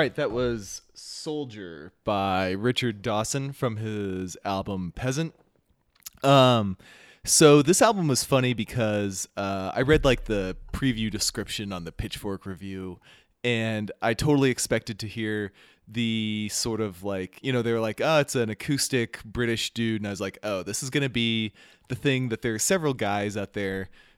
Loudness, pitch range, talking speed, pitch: -26 LUFS, 100-130 Hz, 170 wpm, 110 Hz